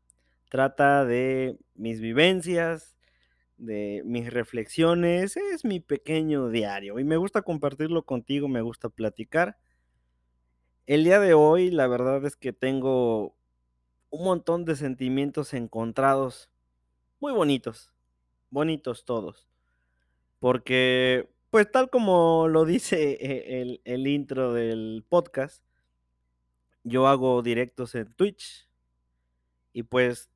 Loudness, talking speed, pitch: -25 LUFS, 110 wpm, 125 Hz